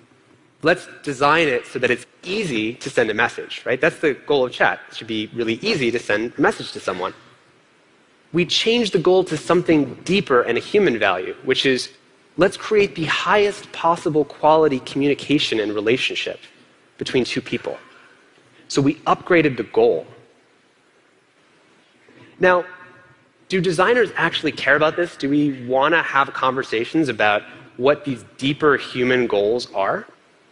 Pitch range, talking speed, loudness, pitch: 135-200 Hz, 155 wpm, -19 LUFS, 160 Hz